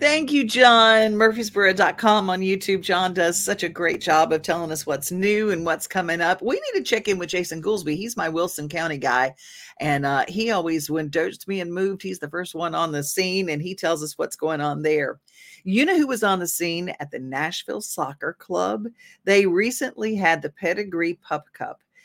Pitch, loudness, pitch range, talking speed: 180 Hz, -22 LUFS, 165-210 Hz, 210 wpm